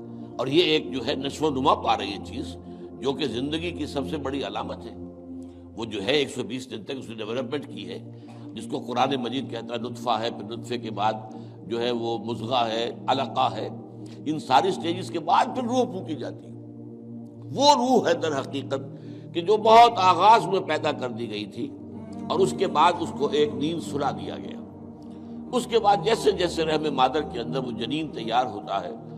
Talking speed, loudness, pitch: 210 wpm, -25 LUFS, 120 Hz